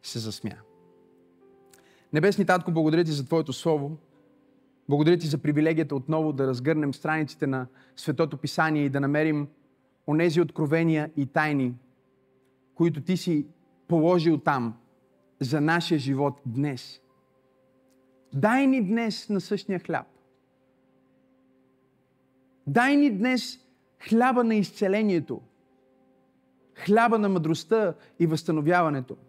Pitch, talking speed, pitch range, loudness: 150 Hz, 110 wpm, 130-170 Hz, -25 LUFS